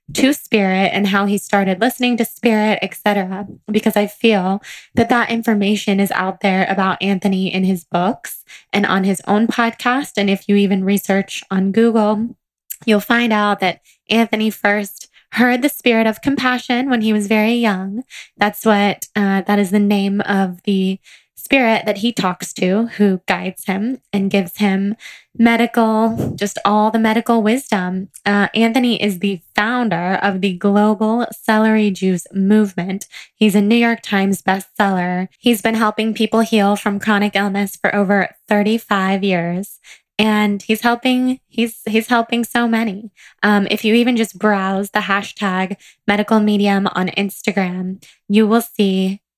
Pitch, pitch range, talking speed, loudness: 205 Hz, 195-225 Hz, 160 wpm, -16 LUFS